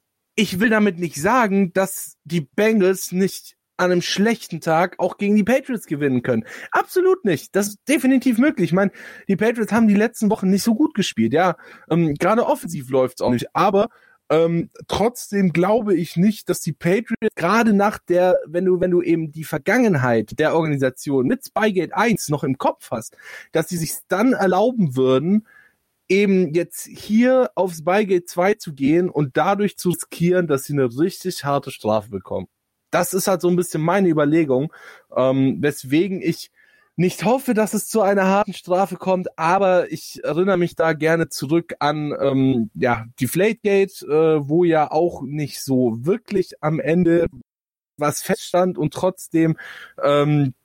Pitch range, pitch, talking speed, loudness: 155-200 Hz, 180 Hz, 170 wpm, -20 LUFS